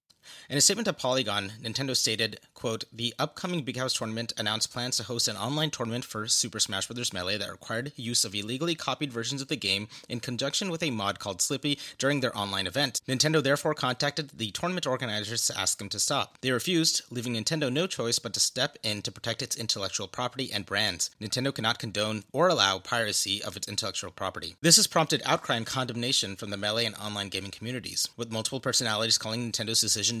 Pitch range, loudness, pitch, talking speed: 105-135 Hz, -28 LUFS, 120 Hz, 205 wpm